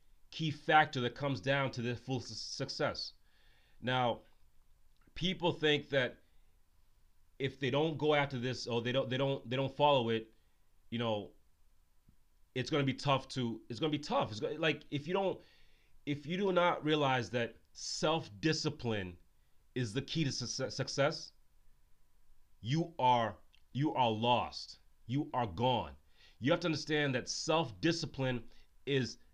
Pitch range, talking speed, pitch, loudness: 100-145 Hz, 150 wpm, 125 Hz, -35 LUFS